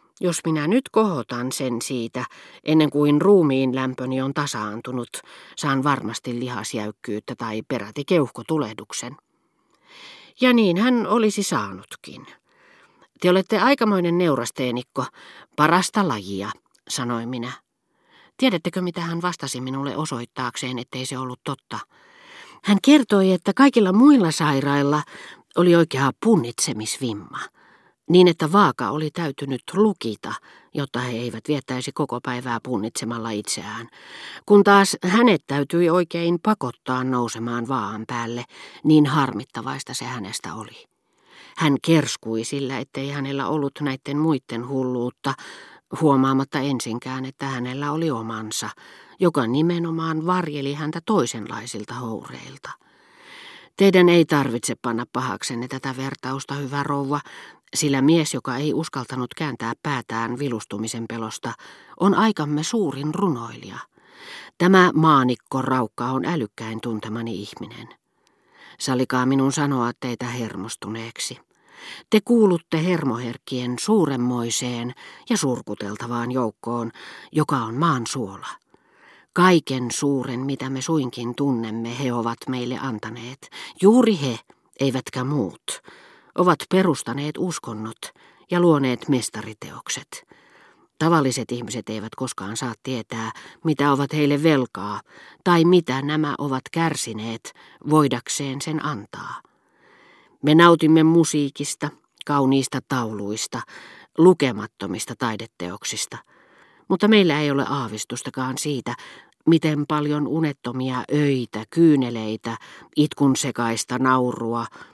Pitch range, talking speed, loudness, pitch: 120-160 Hz, 105 wpm, -22 LUFS, 135 Hz